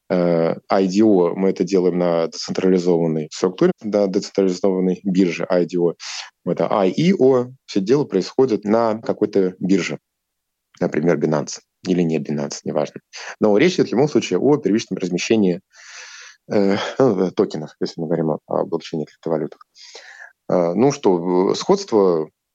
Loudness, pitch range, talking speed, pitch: -19 LUFS, 85-100 Hz, 120 wpm, 95 Hz